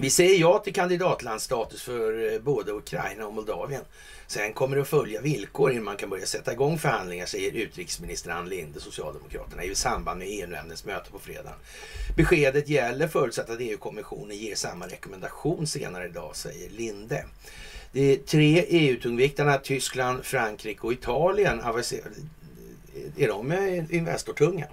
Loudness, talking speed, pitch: -27 LUFS, 140 wpm, 170 Hz